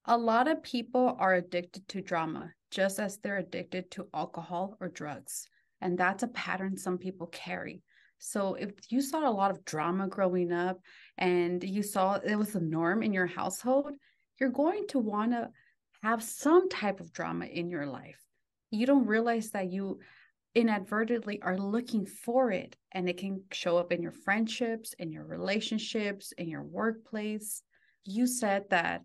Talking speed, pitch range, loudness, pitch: 170 wpm, 180-230 Hz, -32 LUFS, 200 Hz